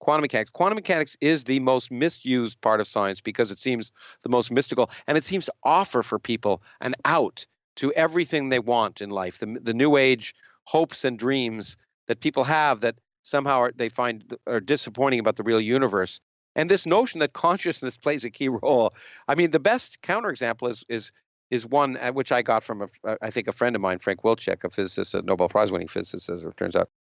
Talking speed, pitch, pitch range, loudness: 210 wpm, 125 Hz, 115-145 Hz, -24 LUFS